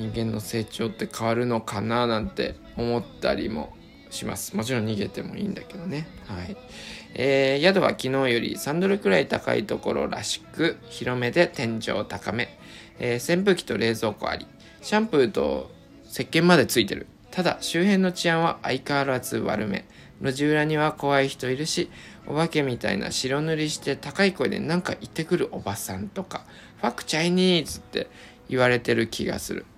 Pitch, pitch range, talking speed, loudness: 135 Hz, 115-170 Hz, 350 characters per minute, -25 LUFS